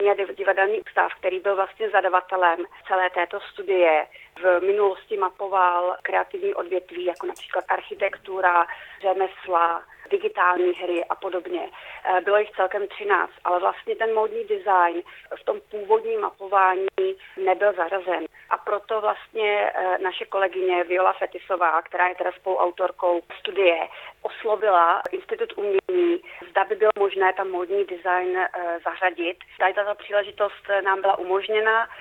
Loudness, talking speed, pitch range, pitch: -23 LUFS, 125 wpm, 180-215 Hz, 195 Hz